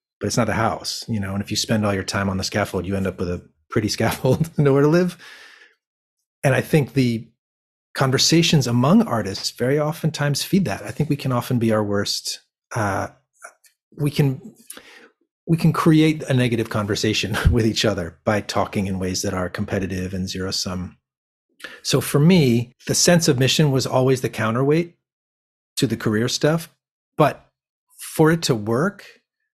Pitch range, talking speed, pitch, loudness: 100-155 Hz, 180 wpm, 120 Hz, -20 LUFS